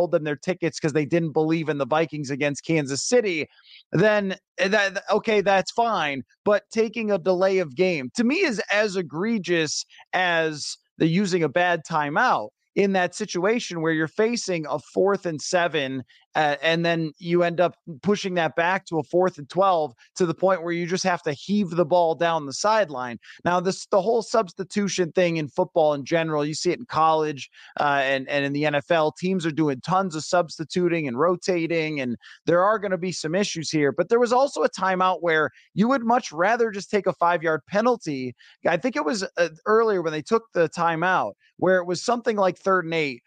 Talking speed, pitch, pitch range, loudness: 205 wpm, 175 Hz, 155-195 Hz, -23 LUFS